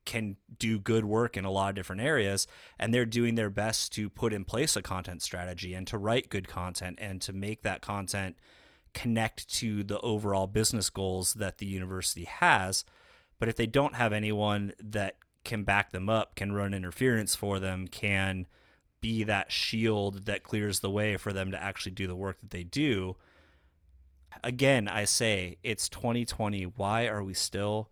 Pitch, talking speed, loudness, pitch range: 100 Hz, 185 wpm, -31 LUFS, 95-110 Hz